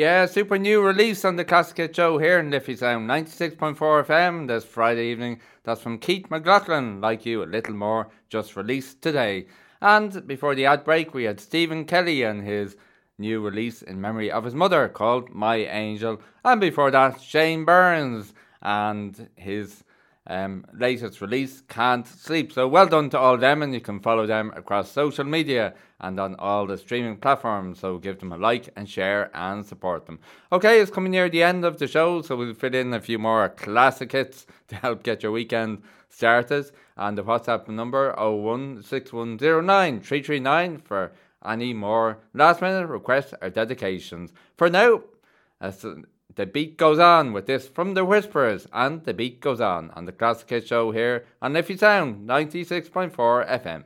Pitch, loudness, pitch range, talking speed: 125 Hz, -22 LUFS, 110-160 Hz, 175 wpm